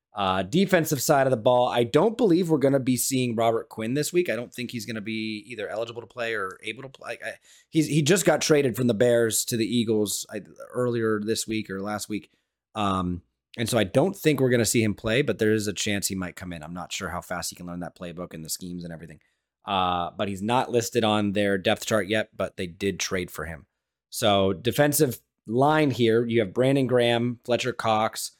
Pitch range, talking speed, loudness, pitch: 100-125 Hz, 240 wpm, -25 LUFS, 115 Hz